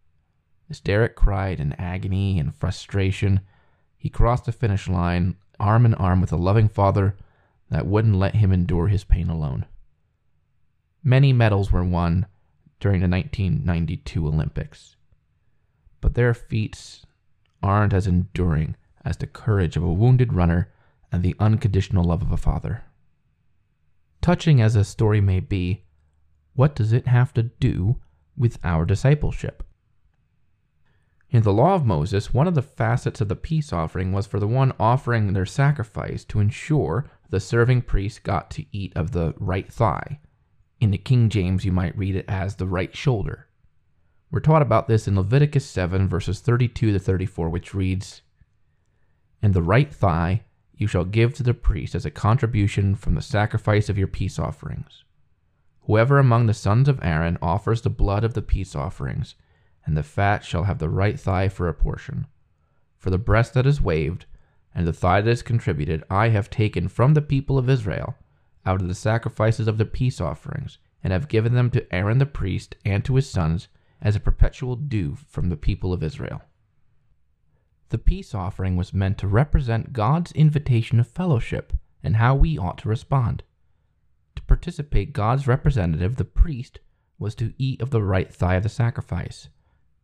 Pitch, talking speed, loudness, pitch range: 100 Hz, 170 wpm, -22 LUFS, 90-120 Hz